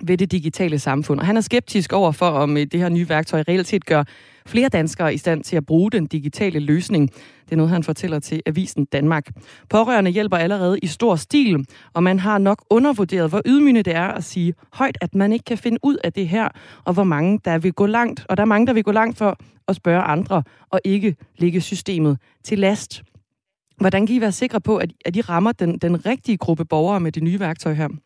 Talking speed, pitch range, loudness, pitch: 230 wpm, 160-205 Hz, -19 LUFS, 180 Hz